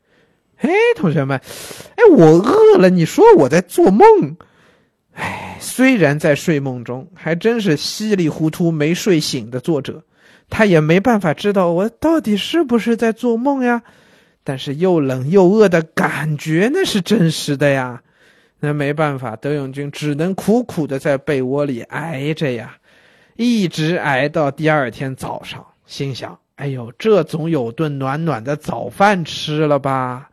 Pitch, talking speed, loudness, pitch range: 160 Hz, 220 characters per minute, -15 LUFS, 145-210 Hz